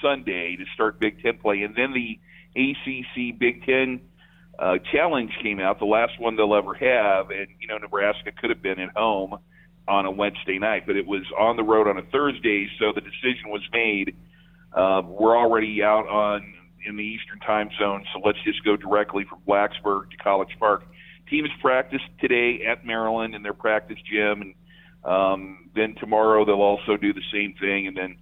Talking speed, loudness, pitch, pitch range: 185 wpm, -23 LUFS, 105 Hz, 100-125 Hz